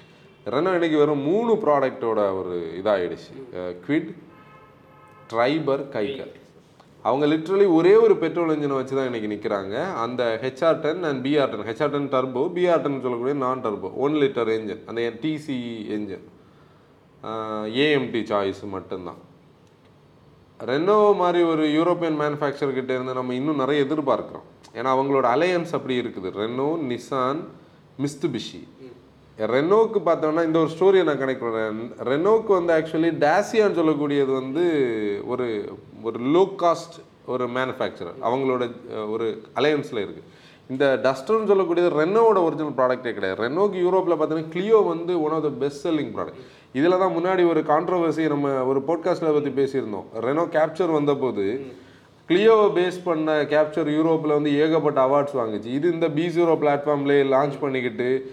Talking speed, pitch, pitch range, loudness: 135 wpm, 145 Hz, 130-165 Hz, -22 LUFS